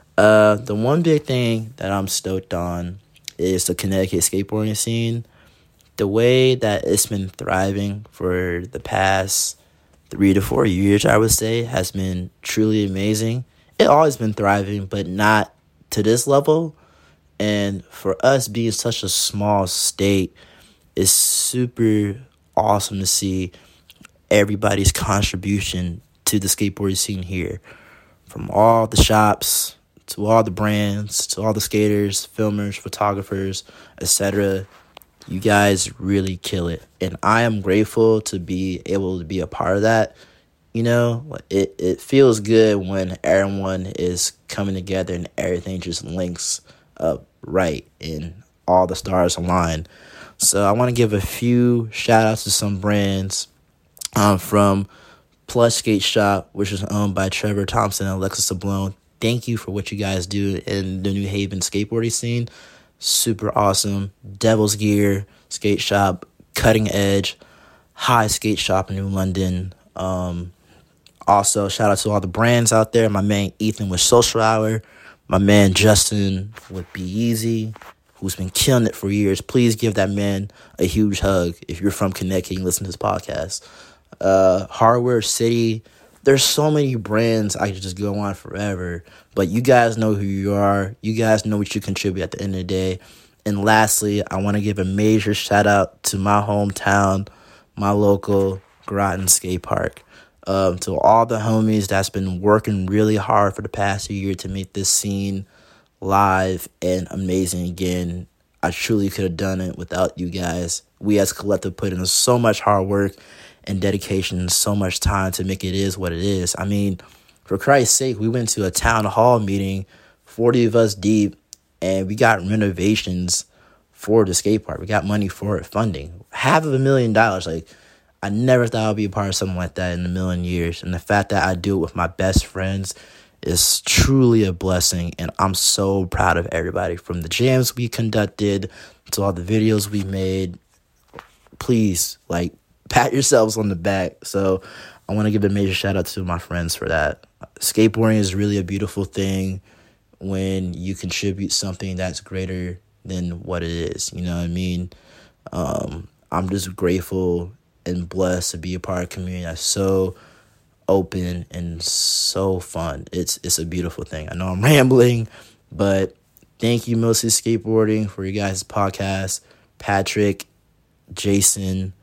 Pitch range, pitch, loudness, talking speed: 95-110 Hz, 100 Hz, -19 LUFS, 170 wpm